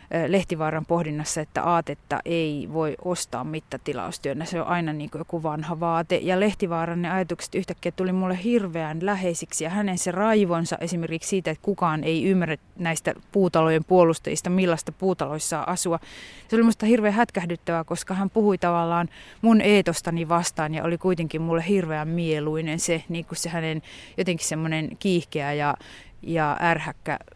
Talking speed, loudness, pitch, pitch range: 150 wpm, -25 LUFS, 170 Hz, 160-185 Hz